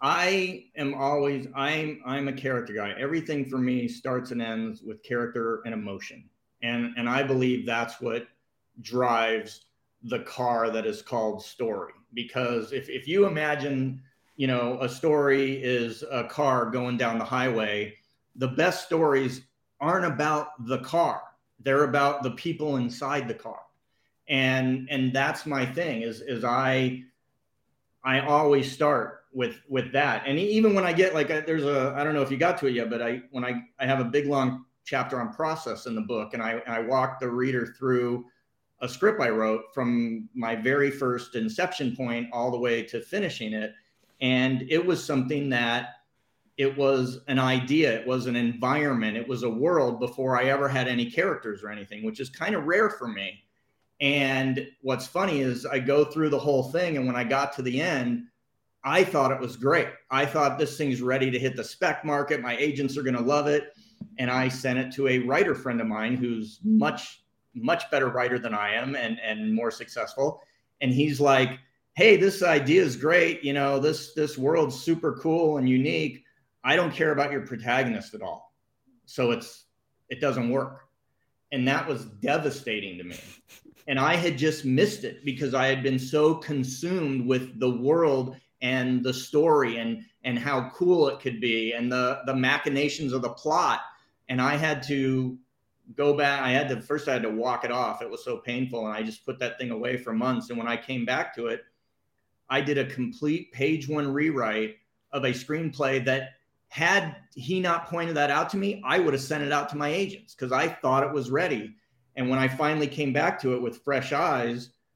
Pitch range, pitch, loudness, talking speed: 120-145 Hz, 130 Hz, -26 LUFS, 195 wpm